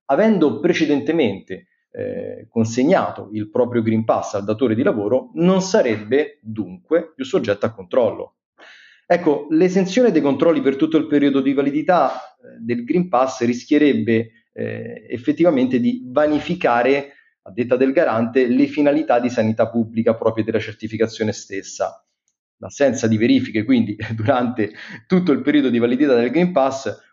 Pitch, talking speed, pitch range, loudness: 135 Hz, 140 wpm, 115-165 Hz, -18 LUFS